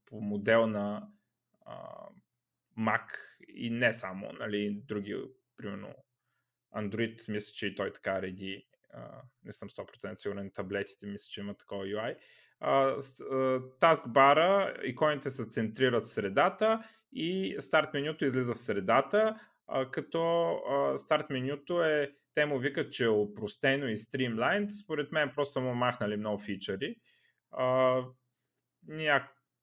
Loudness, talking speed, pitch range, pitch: -31 LUFS, 125 wpm, 105-145 Hz, 130 Hz